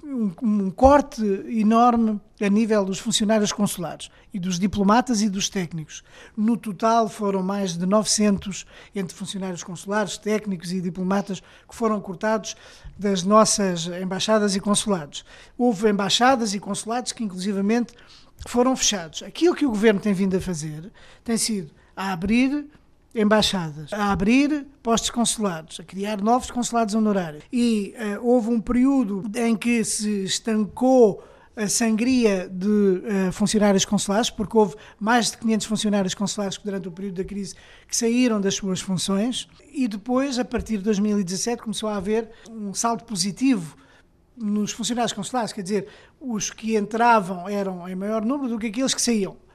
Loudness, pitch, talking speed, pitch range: -22 LUFS, 210 Hz, 155 wpm, 195-230 Hz